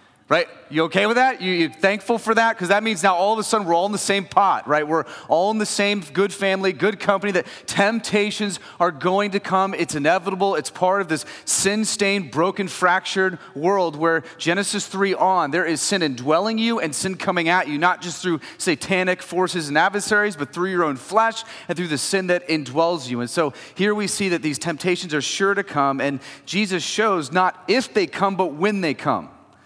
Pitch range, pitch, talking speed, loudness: 170-200 Hz, 185 Hz, 215 wpm, -21 LUFS